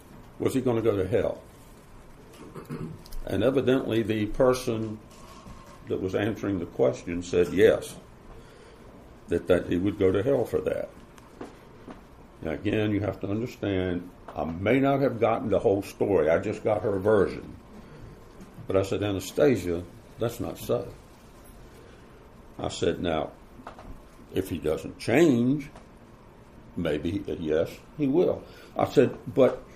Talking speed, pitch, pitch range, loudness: 135 wpm, 110 Hz, 95-125 Hz, -27 LUFS